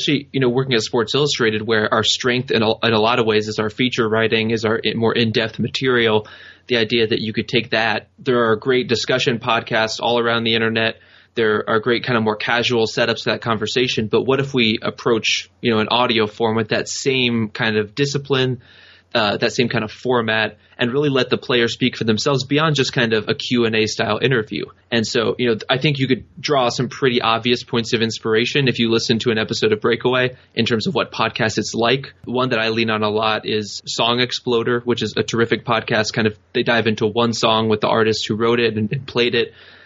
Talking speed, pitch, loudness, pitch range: 230 wpm, 115 Hz, -18 LUFS, 110-125 Hz